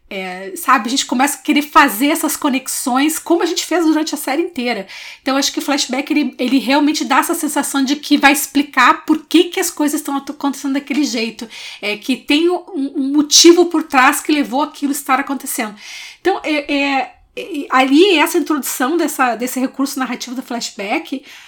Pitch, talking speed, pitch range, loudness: 285 Hz, 195 wpm, 265-310 Hz, -15 LUFS